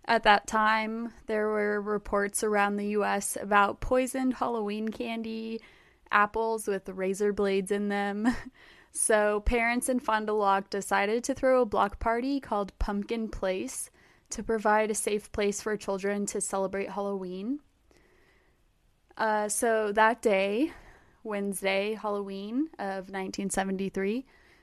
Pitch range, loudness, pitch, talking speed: 200-225 Hz, -29 LUFS, 210 Hz, 125 wpm